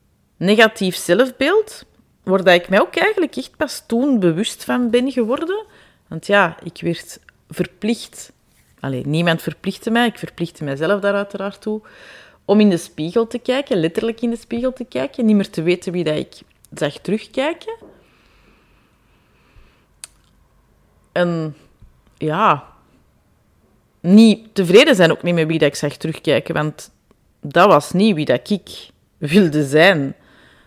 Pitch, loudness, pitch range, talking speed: 200 Hz, -17 LUFS, 165-235 Hz, 140 wpm